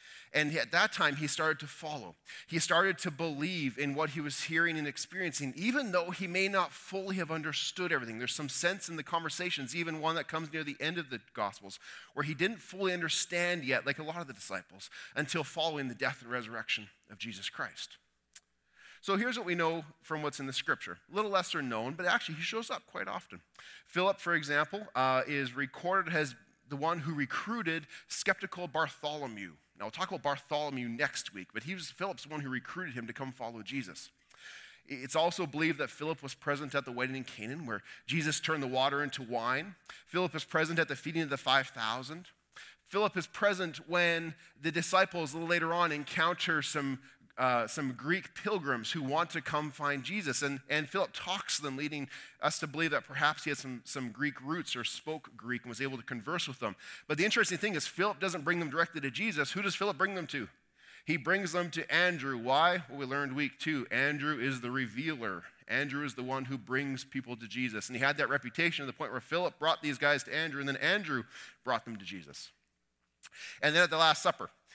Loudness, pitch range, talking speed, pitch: -33 LUFS, 135-170 Hz, 215 wpm, 150 Hz